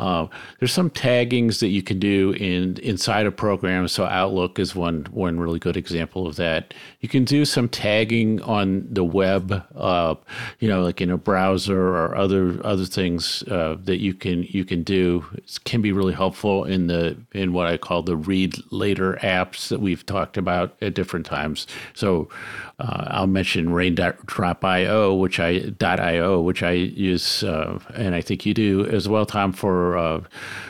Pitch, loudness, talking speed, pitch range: 95 Hz, -22 LUFS, 180 wpm, 90-100 Hz